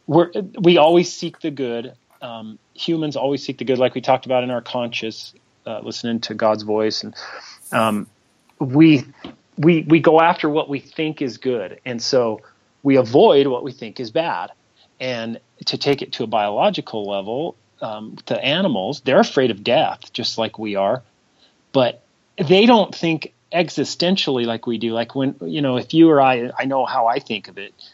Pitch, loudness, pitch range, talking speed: 135 Hz, -19 LUFS, 115-160 Hz, 185 wpm